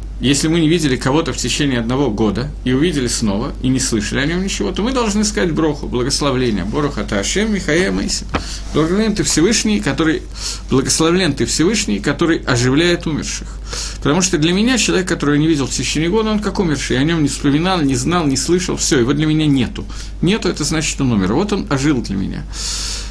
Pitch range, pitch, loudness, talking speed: 130-175 Hz, 150 Hz, -16 LUFS, 205 wpm